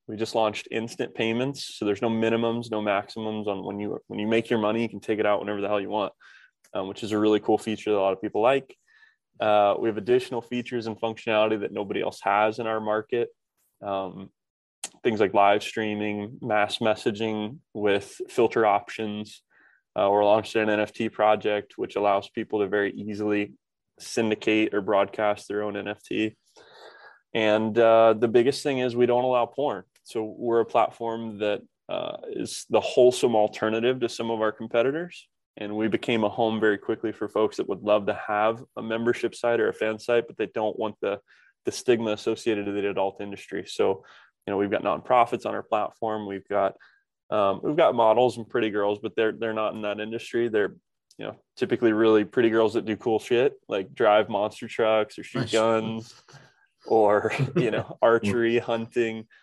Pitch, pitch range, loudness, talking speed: 110 Hz, 105-115 Hz, -25 LUFS, 195 wpm